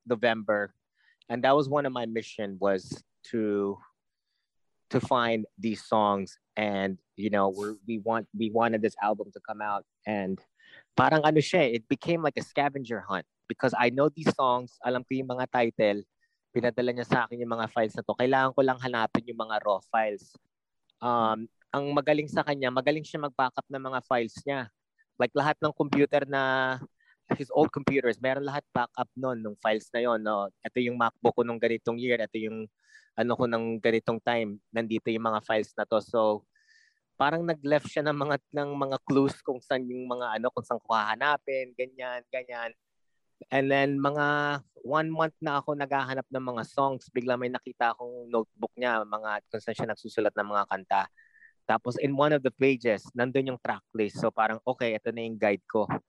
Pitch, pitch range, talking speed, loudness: 125 Hz, 110-140 Hz, 185 wpm, -29 LUFS